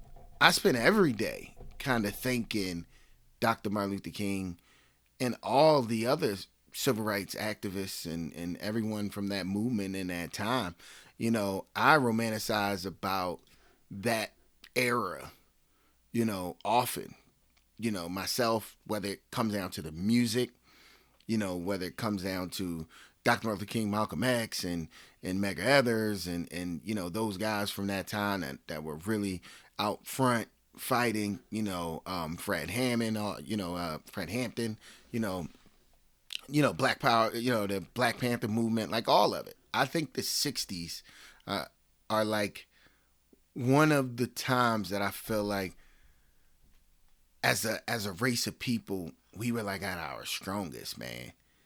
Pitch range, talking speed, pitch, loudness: 85-115 Hz, 155 wpm, 100 Hz, -31 LUFS